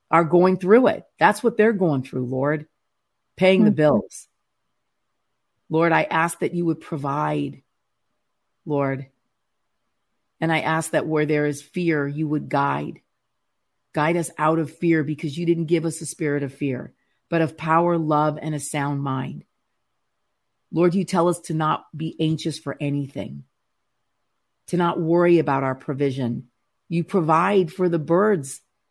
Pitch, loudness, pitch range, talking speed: 160 Hz, -22 LUFS, 145-170 Hz, 155 wpm